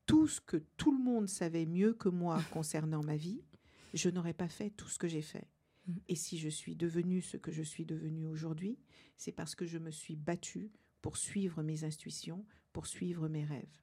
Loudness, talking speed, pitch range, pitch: -39 LUFS, 210 wpm, 160-190 Hz, 170 Hz